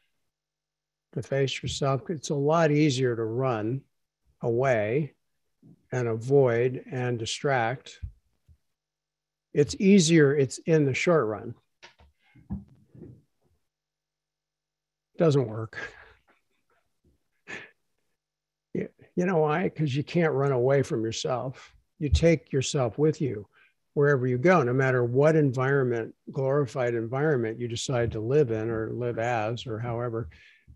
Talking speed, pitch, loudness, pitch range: 115 wpm, 135 Hz, -26 LUFS, 115-150 Hz